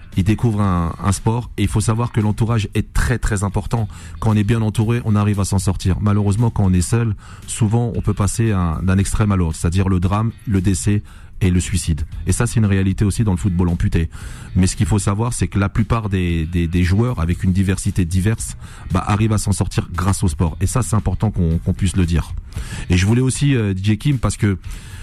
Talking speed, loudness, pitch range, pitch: 240 wpm, -18 LUFS, 90-110 Hz, 100 Hz